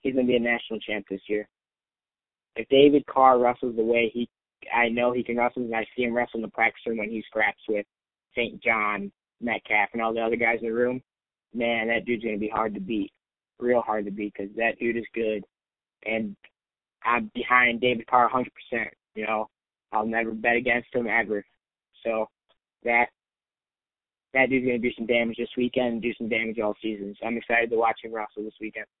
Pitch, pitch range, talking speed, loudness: 115 Hz, 110-120 Hz, 215 wpm, -25 LUFS